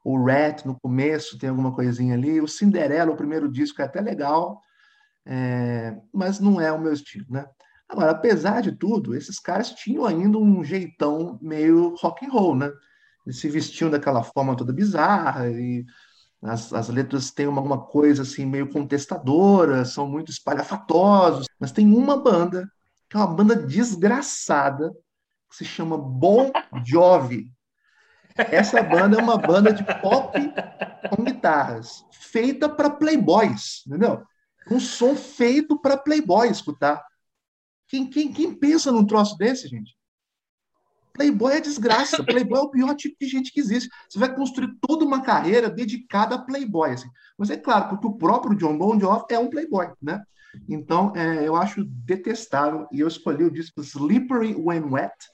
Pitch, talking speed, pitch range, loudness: 185 Hz, 160 wpm, 145-240 Hz, -21 LUFS